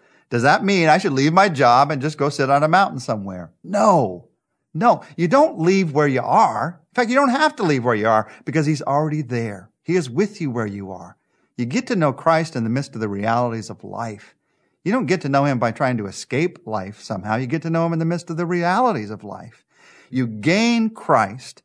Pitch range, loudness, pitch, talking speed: 115-175 Hz, -19 LUFS, 150 Hz, 240 wpm